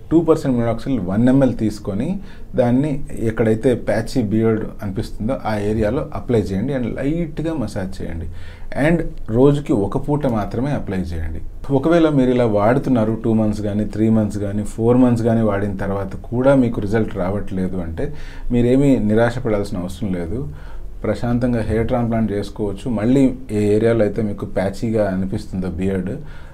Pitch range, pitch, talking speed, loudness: 100-125 Hz, 110 Hz, 140 wpm, -19 LUFS